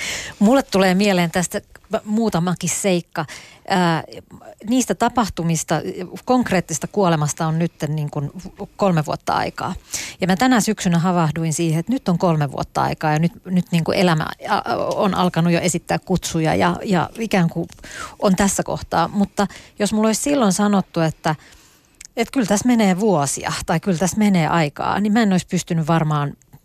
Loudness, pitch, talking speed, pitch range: -19 LUFS, 185 Hz, 155 wpm, 165-205 Hz